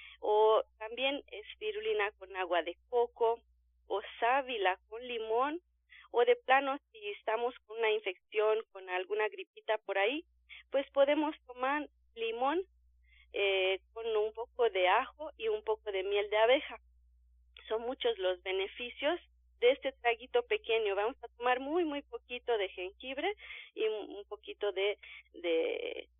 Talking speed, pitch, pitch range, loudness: 140 wpm, 230 Hz, 195-275 Hz, -34 LUFS